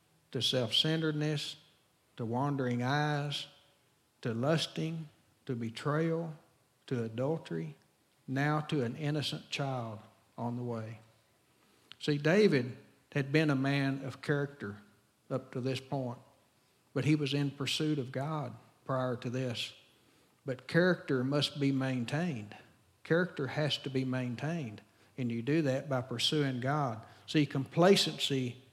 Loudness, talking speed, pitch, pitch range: -33 LUFS, 125 wpm, 135 Hz, 120-150 Hz